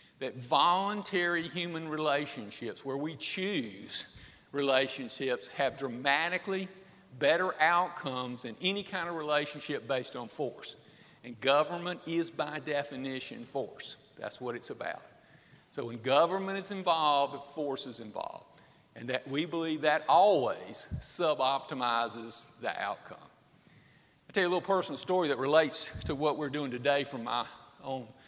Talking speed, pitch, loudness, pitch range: 135 wpm, 150 Hz, -32 LUFS, 135-175 Hz